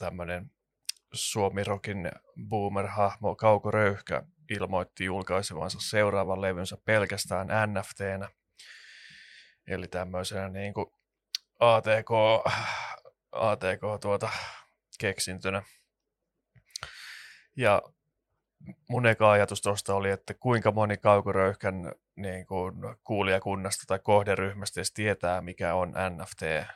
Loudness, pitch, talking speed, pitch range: -29 LUFS, 100 Hz, 85 wpm, 95-105 Hz